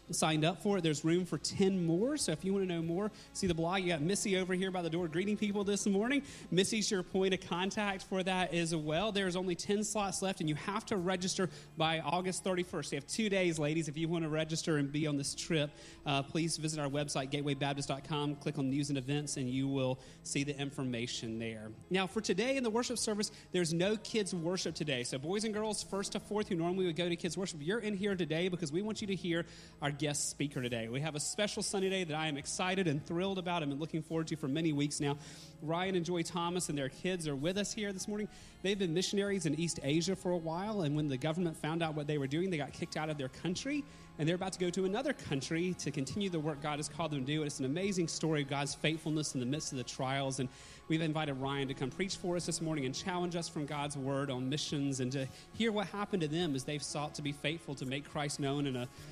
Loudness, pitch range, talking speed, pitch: -36 LUFS, 145-190 Hz, 260 wpm, 165 Hz